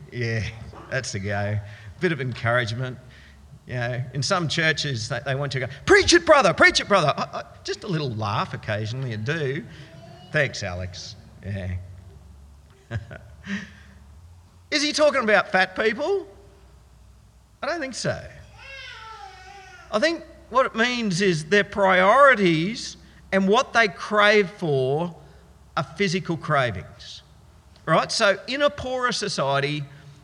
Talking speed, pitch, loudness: 135 wpm, 150 Hz, -22 LUFS